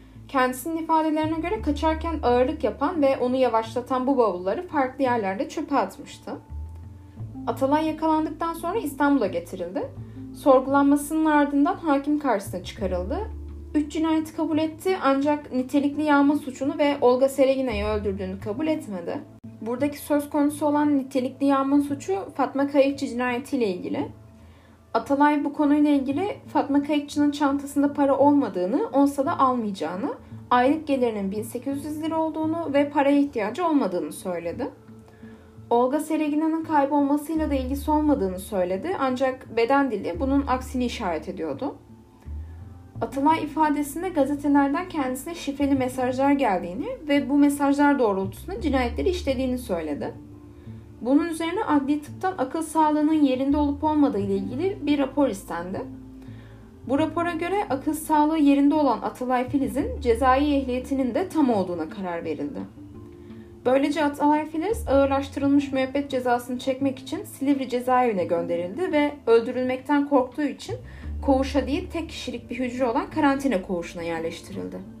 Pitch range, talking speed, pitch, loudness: 215-295 Hz, 125 wpm, 275 Hz, -24 LUFS